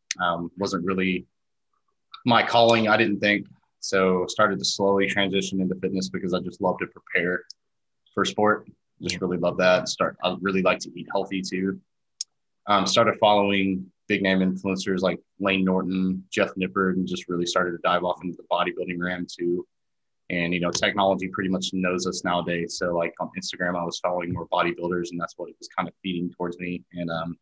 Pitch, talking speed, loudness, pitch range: 95 Hz, 195 wpm, -24 LUFS, 90-95 Hz